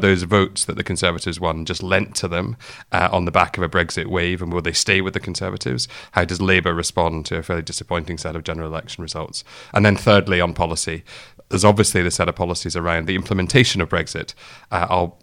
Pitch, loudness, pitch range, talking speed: 90 Hz, -20 LUFS, 85-95 Hz, 230 wpm